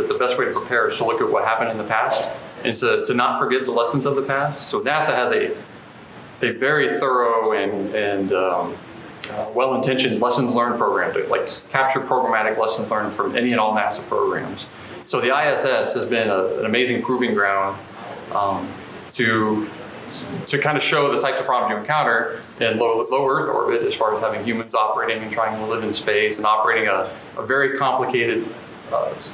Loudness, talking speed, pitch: -20 LUFS, 200 wpm, 120 Hz